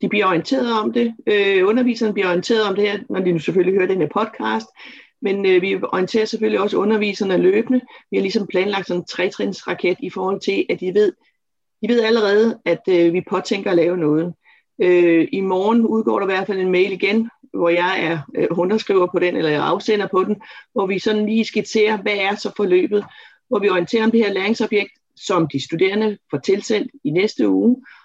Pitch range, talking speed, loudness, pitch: 180-220 Hz, 205 wpm, -18 LUFS, 200 Hz